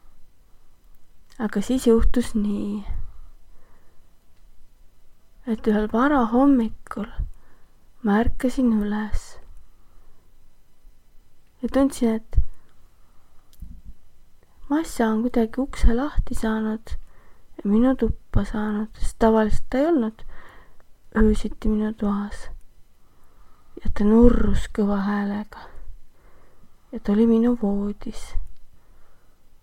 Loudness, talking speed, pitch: -23 LUFS, 80 wpm, 210 Hz